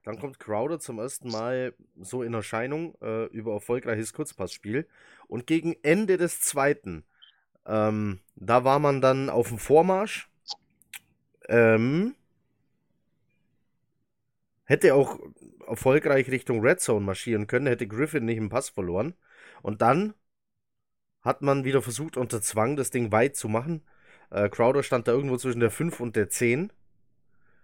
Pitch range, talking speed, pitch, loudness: 110-140 Hz, 140 wpm, 120 Hz, -26 LUFS